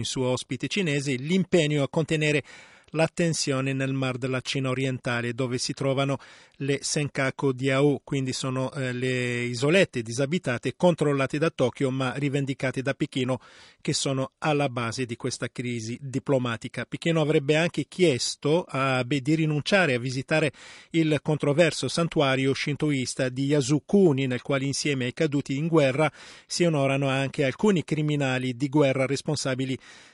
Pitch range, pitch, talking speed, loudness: 130-155 Hz, 140 Hz, 140 wpm, -26 LUFS